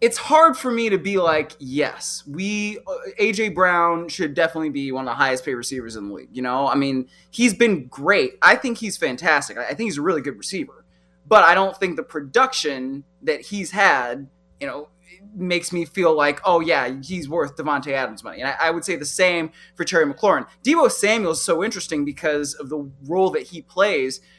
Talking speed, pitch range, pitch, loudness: 210 wpm, 145-200 Hz, 170 Hz, -20 LUFS